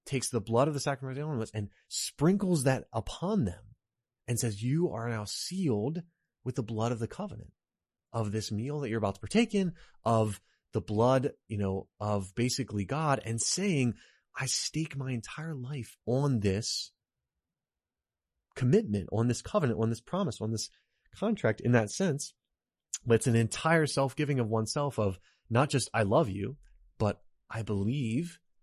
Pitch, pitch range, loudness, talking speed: 120 Hz, 110-140 Hz, -31 LUFS, 170 wpm